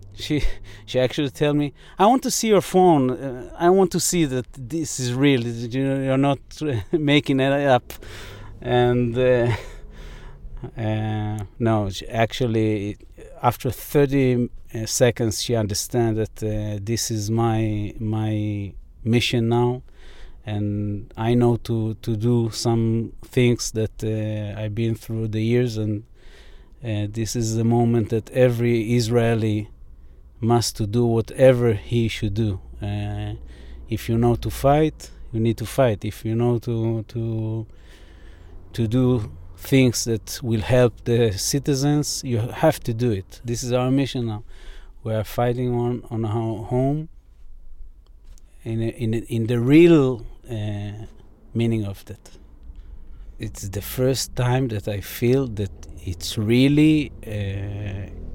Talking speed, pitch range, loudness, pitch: 140 wpm, 105-125 Hz, -22 LUFS, 115 Hz